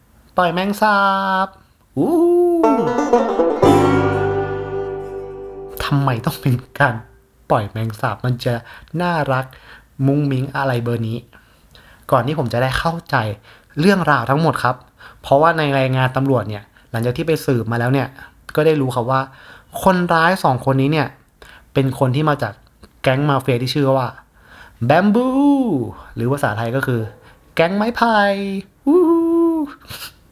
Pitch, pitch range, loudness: 135 Hz, 120-175 Hz, -18 LUFS